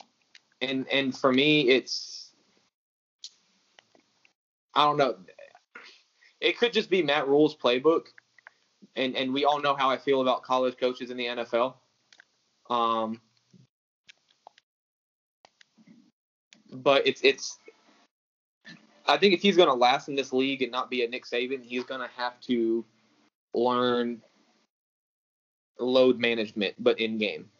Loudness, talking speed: -26 LUFS, 125 wpm